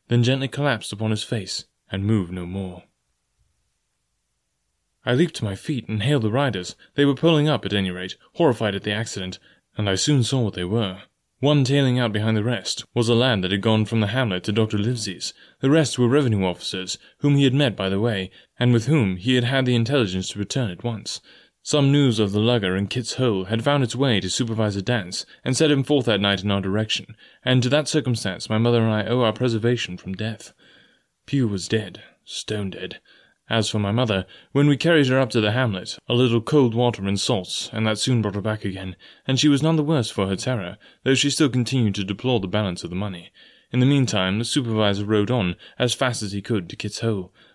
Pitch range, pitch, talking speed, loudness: 100-130 Hz, 115 Hz, 230 wpm, -22 LUFS